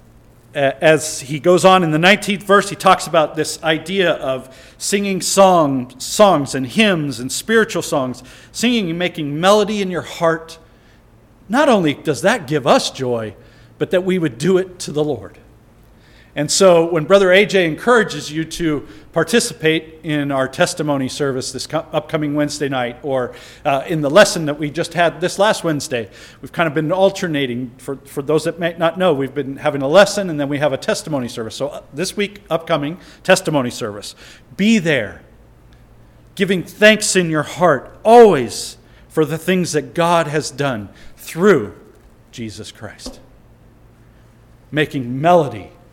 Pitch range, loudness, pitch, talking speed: 135-180 Hz, -16 LUFS, 155 Hz, 160 wpm